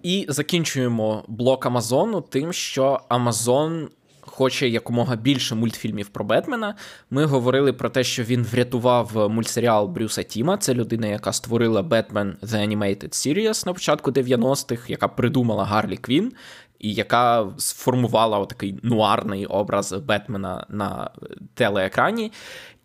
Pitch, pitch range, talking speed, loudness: 120 Hz, 110-135 Hz, 125 wpm, -22 LUFS